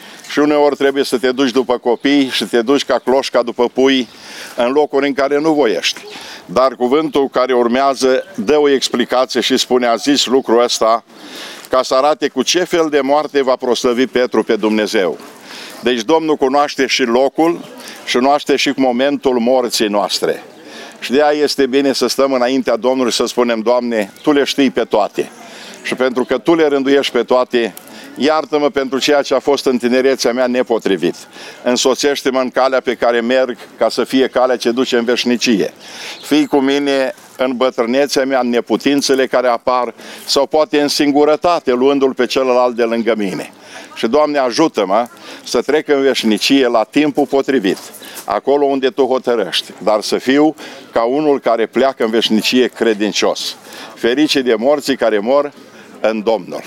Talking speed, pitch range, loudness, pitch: 170 wpm, 125-140 Hz, -14 LUFS, 130 Hz